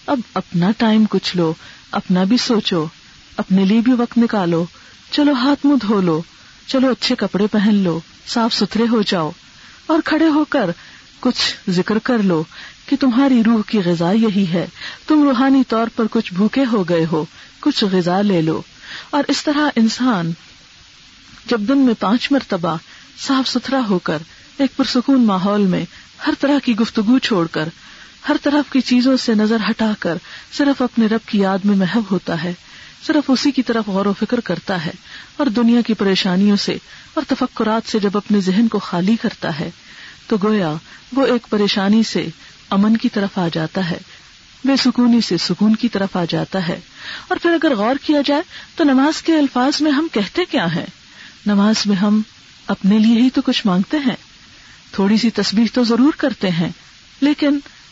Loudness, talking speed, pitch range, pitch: -17 LUFS, 180 wpm, 195-265 Hz, 225 Hz